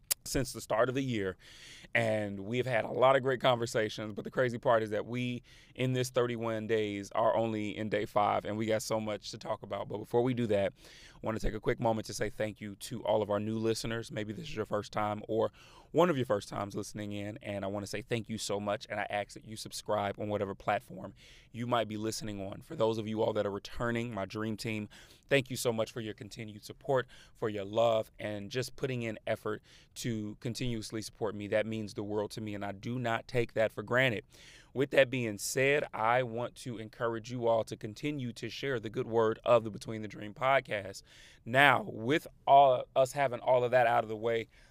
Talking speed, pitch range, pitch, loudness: 240 wpm, 105-120 Hz, 110 Hz, -33 LUFS